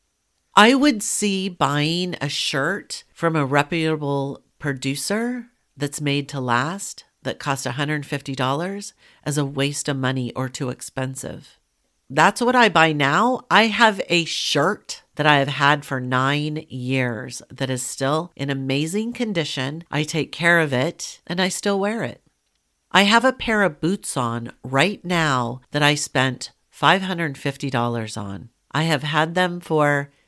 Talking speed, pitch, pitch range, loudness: 150 wpm, 150 Hz, 135-180 Hz, -21 LUFS